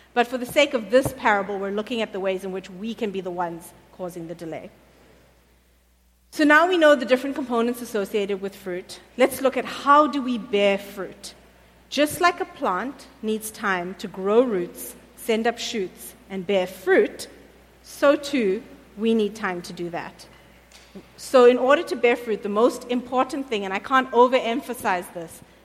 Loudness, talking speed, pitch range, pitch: -22 LUFS, 185 wpm, 190-255 Hz, 220 Hz